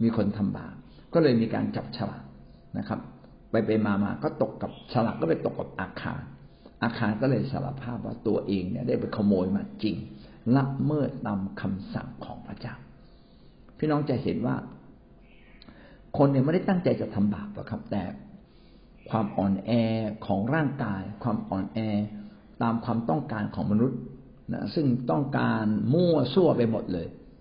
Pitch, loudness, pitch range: 115 Hz, -28 LUFS, 105-130 Hz